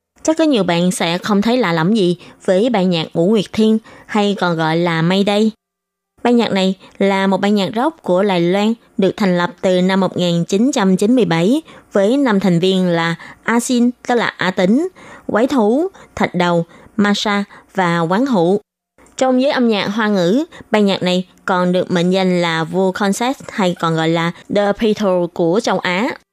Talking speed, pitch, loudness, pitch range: 185 wpm, 195 Hz, -16 LUFS, 180-230 Hz